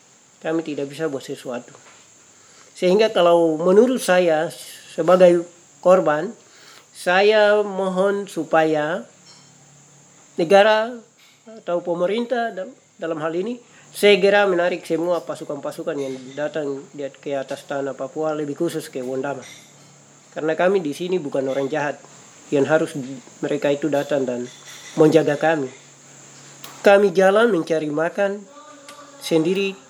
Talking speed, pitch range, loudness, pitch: 110 wpm, 145-195 Hz, -20 LUFS, 165 Hz